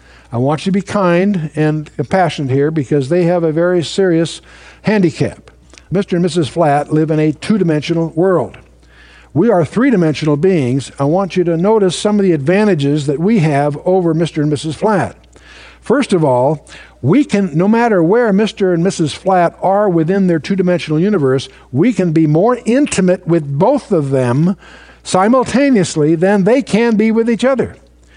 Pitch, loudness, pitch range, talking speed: 175 Hz, -13 LUFS, 150-195 Hz, 175 wpm